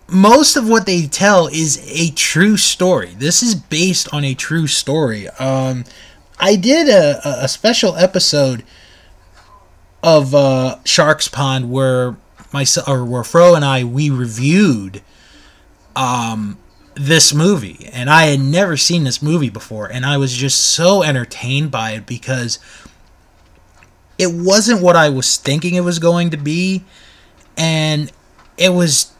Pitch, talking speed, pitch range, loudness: 145 Hz, 145 wpm, 125-175 Hz, -13 LUFS